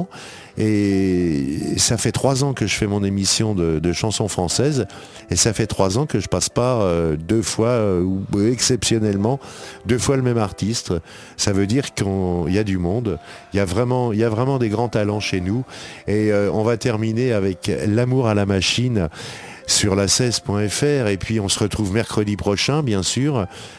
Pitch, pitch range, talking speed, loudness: 105 Hz, 95-120 Hz, 180 wpm, -19 LUFS